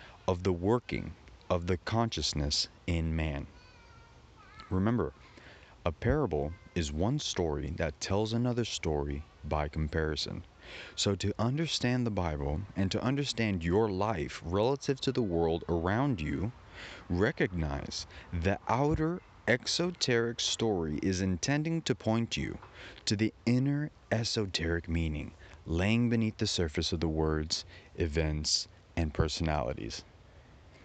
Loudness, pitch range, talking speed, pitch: -32 LUFS, 80-115 Hz, 120 wpm, 95 Hz